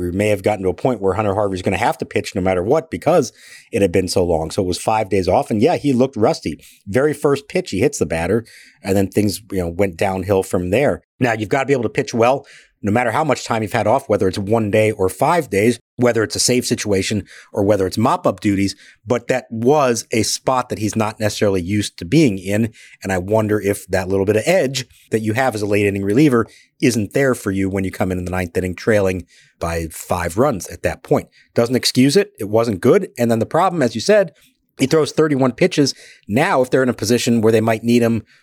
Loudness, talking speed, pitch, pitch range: -18 LUFS, 255 wpm, 110 Hz, 100-125 Hz